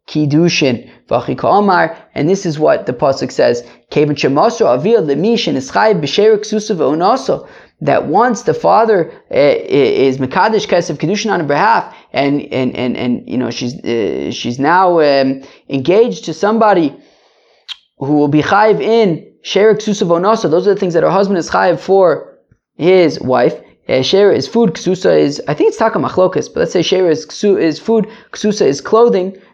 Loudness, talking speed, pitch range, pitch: -13 LUFS, 140 wpm, 150-215 Hz, 185 Hz